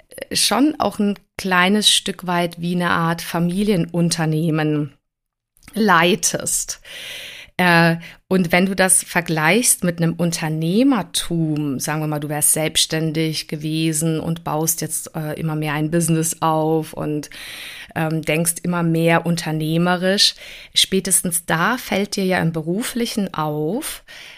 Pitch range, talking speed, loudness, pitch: 155-185 Hz, 115 wpm, -18 LUFS, 165 Hz